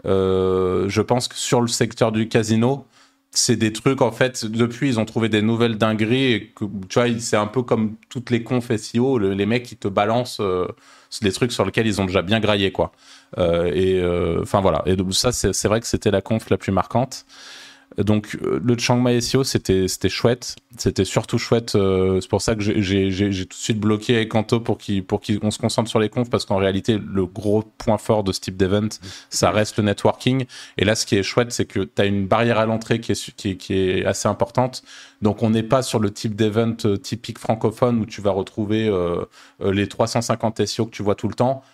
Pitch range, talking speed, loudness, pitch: 100-120 Hz, 225 wpm, -21 LUFS, 110 Hz